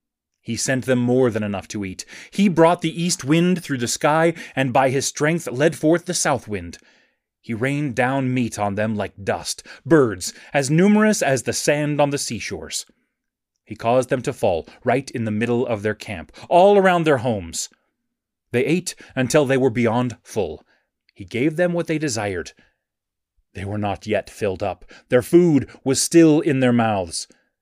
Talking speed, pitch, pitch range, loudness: 180 wpm, 130 Hz, 110-155 Hz, -20 LUFS